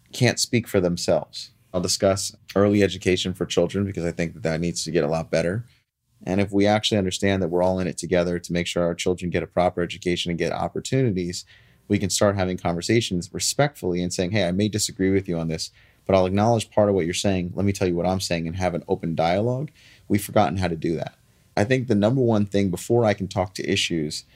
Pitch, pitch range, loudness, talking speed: 95 Hz, 90-105 Hz, -23 LUFS, 240 wpm